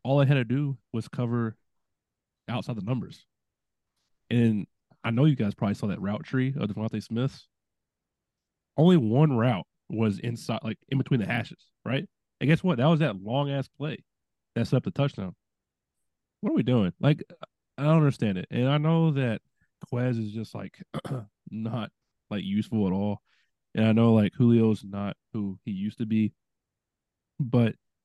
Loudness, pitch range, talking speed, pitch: -27 LUFS, 105-135 Hz, 175 wpm, 115 Hz